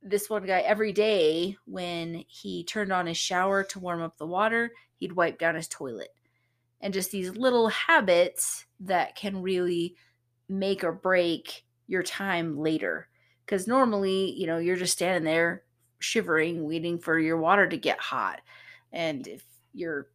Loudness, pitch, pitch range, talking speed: -27 LUFS, 180 Hz, 165-200 Hz, 160 wpm